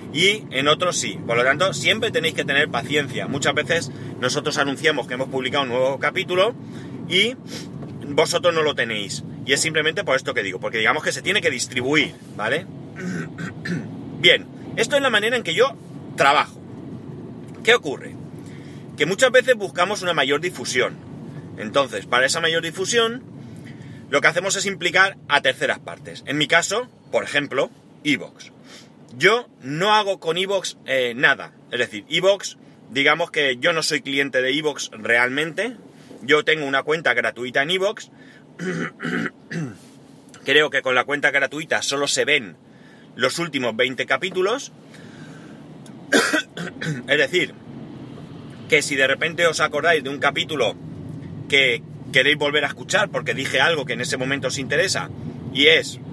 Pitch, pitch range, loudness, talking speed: 150 Hz, 135-180 Hz, -20 LUFS, 155 wpm